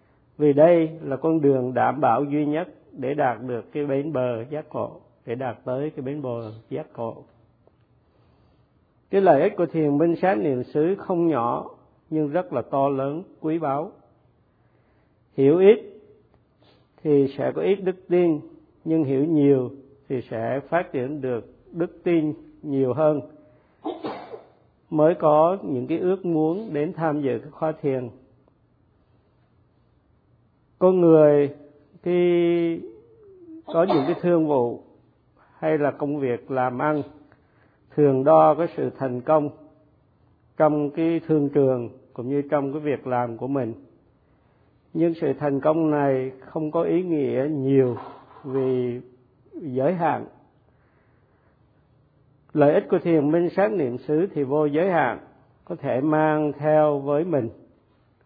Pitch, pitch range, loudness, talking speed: 145 Hz, 130-160 Hz, -23 LUFS, 140 wpm